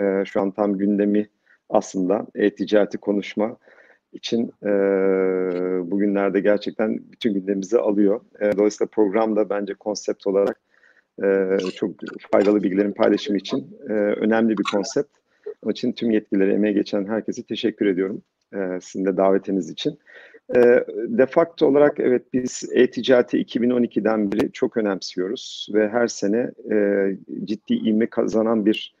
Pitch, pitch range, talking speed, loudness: 105 Hz, 100-115 Hz, 130 wpm, -21 LUFS